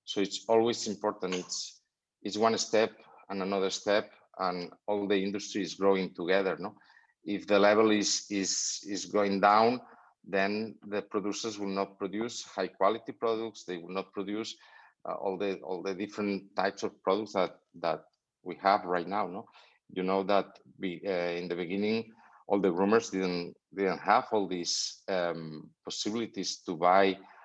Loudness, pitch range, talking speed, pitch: -31 LUFS, 95-105 Hz, 165 wpm, 100 Hz